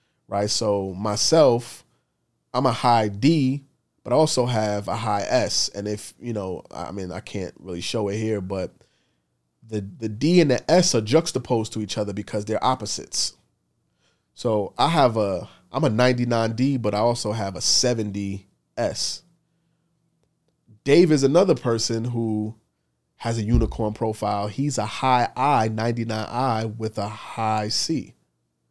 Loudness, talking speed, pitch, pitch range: -23 LUFS, 150 wpm, 110 Hz, 100-125 Hz